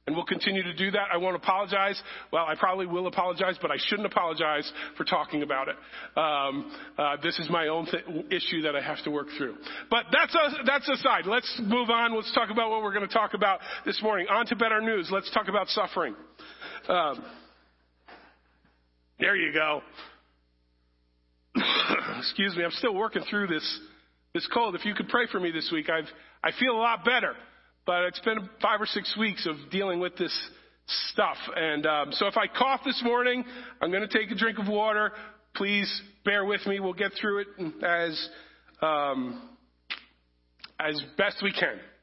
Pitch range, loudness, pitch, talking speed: 155-220 Hz, -28 LUFS, 195 Hz, 190 wpm